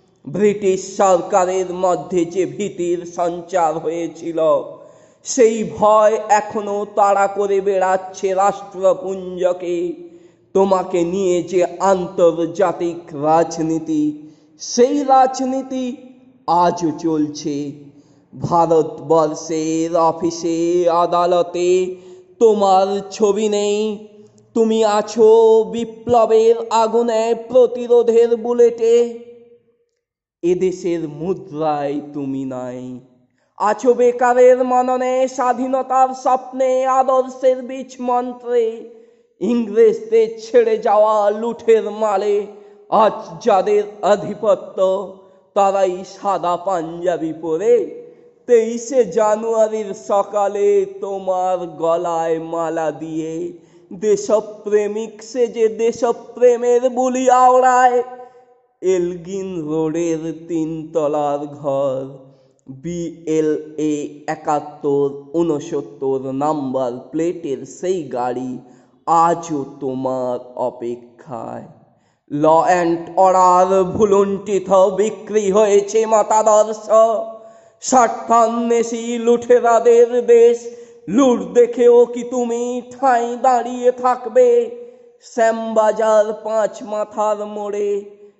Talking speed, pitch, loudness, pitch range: 70 wpm, 200 Hz, -17 LUFS, 170-235 Hz